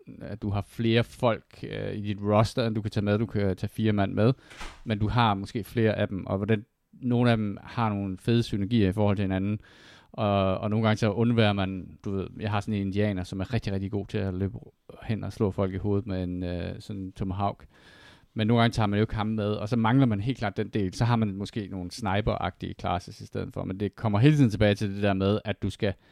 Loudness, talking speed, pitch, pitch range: -27 LUFS, 260 wpm, 105 Hz, 100-110 Hz